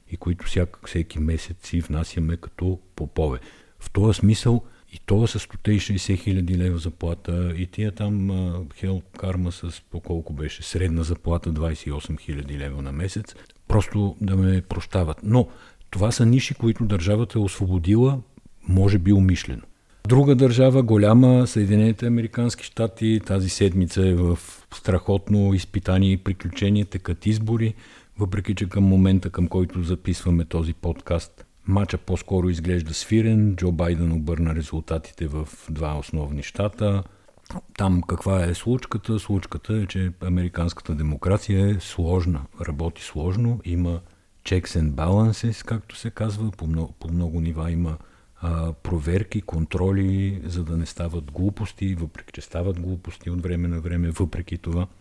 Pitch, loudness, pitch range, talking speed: 90 Hz, -23 LUFS, 85-105 Hz, 145 wpm